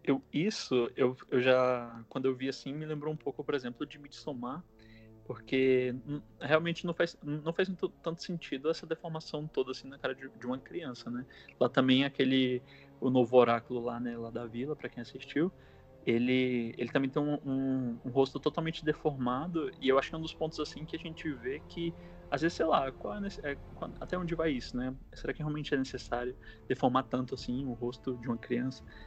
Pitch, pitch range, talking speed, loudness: 135 Hz, 125-155 Hz, 210 wpm, -33 LUFS